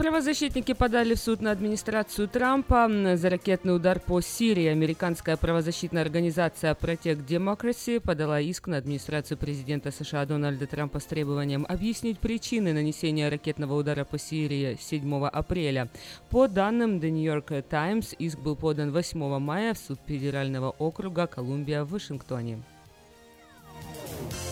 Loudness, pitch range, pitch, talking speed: -28 LUFS, 145-195 Hz, 160 Hz, 130 wpm